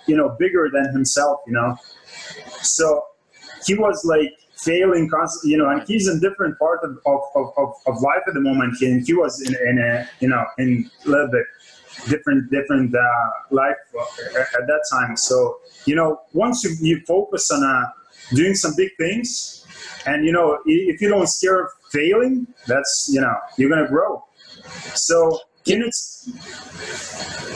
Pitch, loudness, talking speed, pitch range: 160 Hz, -19 LUFS, 170 wpm, 135-210 Hz